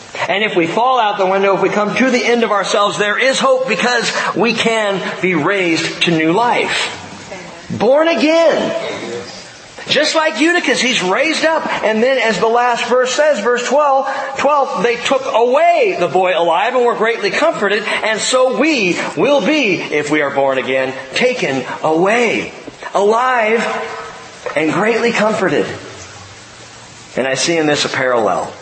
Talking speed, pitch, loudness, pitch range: 160 wpm, 225 Hz, -14 LUFS, 180-265 Hz